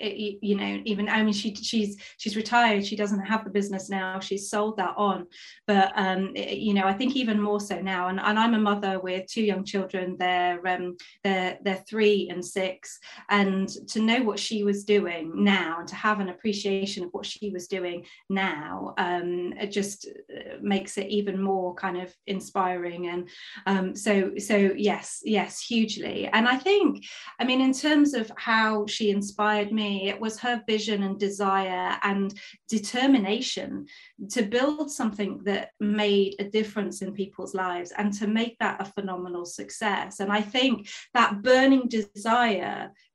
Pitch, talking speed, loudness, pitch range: 205 Hz, 175 wpm, -26 LUFS, 190-220 Hz